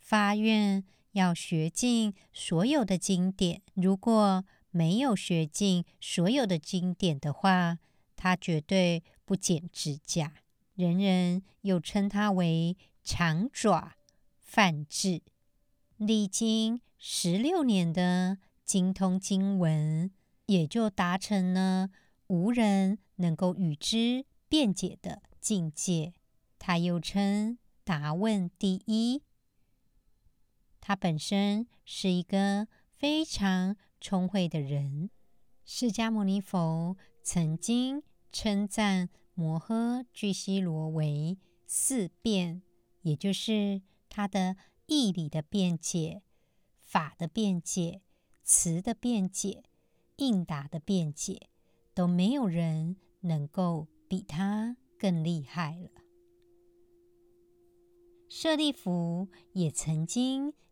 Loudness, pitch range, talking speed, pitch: -30 LUFS, 170-215 Hz, 140 characters per minute, 190 Hz